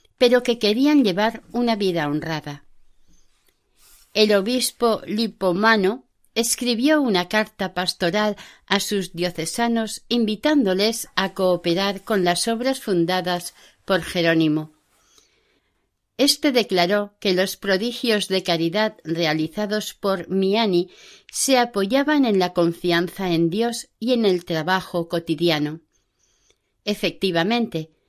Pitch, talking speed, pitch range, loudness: 195 Hz, 105 wpm, 175-225 Hz, -21 LUFS